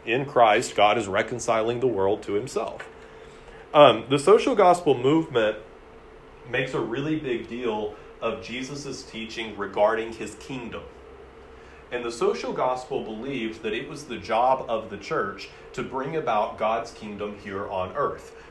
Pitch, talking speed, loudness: 145 Hz, 150 wpm, -25 LUFS